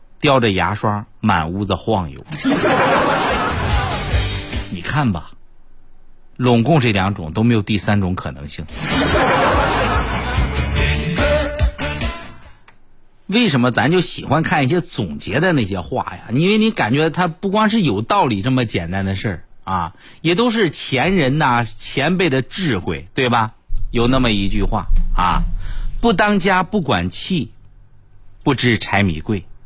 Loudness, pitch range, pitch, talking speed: -17 LUFS, 95-135 Hz, 110 Hz, 190 characters per minute